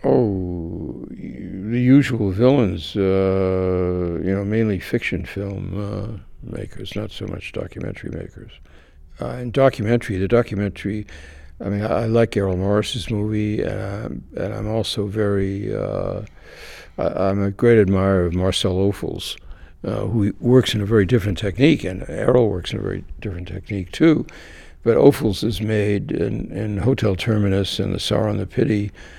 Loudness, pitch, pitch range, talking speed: -20 LUFS, 100 Hz, 95-110 Hz, 155 wpm